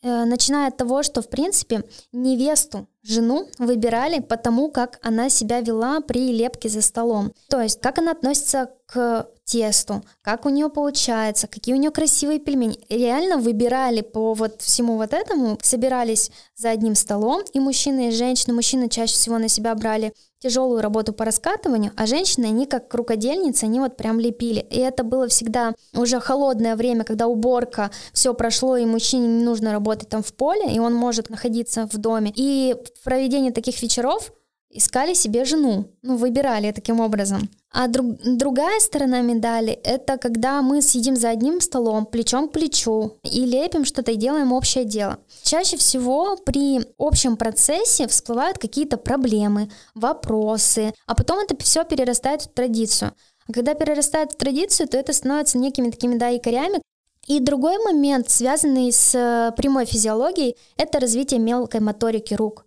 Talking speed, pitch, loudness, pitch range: 160 wpm, 245 Hz, -20 LUFS, 225-270 Hz